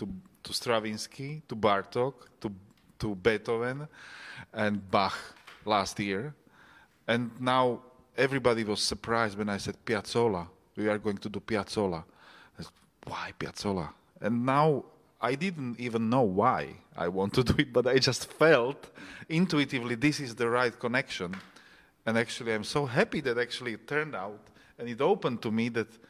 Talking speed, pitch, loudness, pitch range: 155 wpm, 115 Hz, -30 LUFS, 105-130 Hz